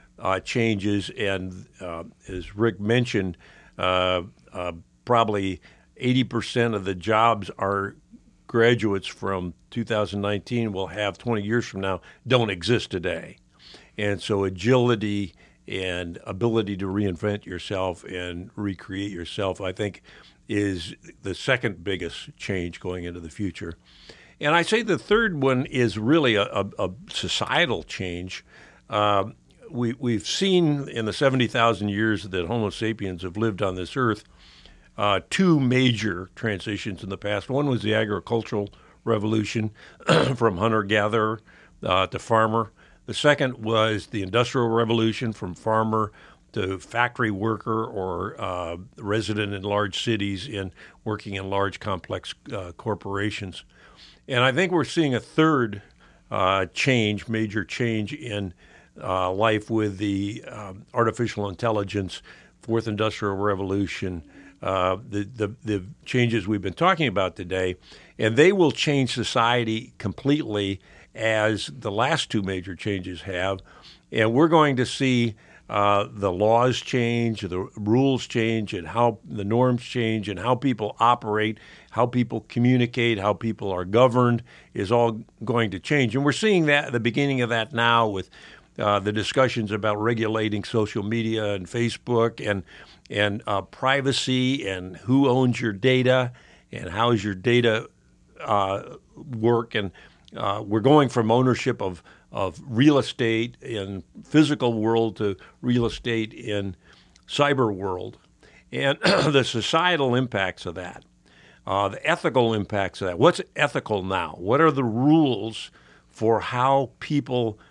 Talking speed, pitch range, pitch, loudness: 140 wpm, 95-120 Hz, 110 Hz, -24 LUFS